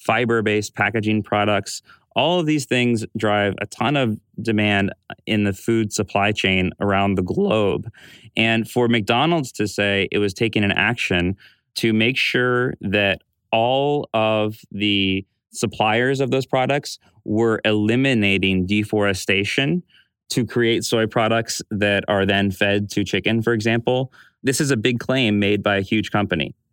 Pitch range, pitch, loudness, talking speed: 100-120 Hz, 110 Hz, -20 LUFS, 150 wpm